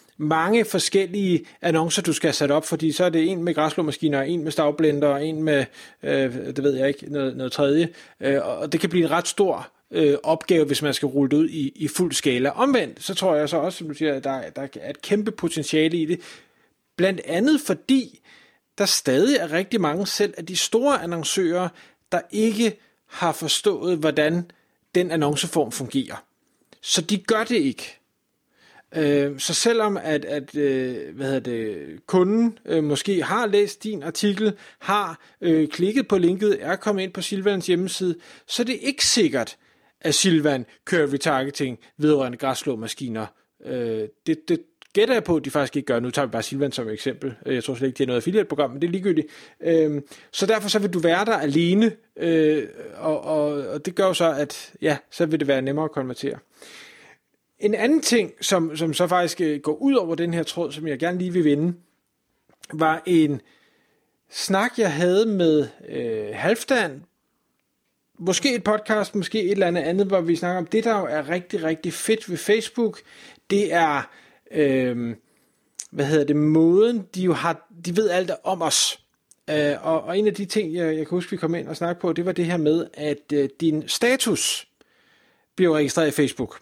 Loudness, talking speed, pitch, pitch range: -22 LUFS, 190 wpm, 165 Hz, 145-195 Hz